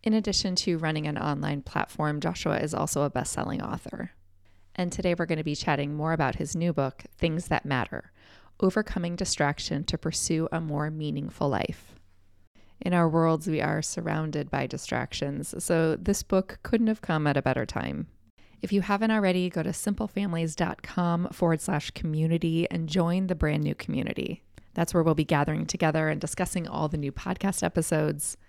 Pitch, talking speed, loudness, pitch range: 165 Hz, 175 wpm, -28 LUFS, 150-180 Hz